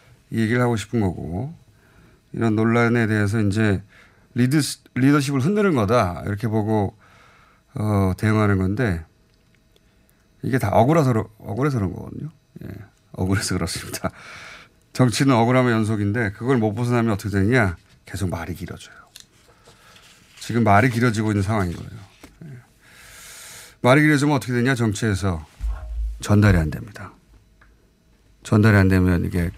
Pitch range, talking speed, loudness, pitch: 95-125 Hz, 295 characters per minute, -20 LUFS, 110 Hz